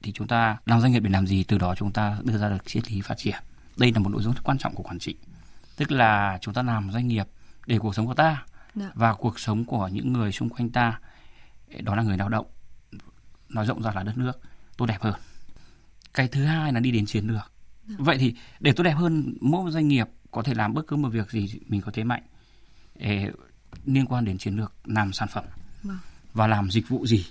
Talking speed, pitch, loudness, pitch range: 240 wpm, 110 Hz, -26 LUFS, 105-125 Hz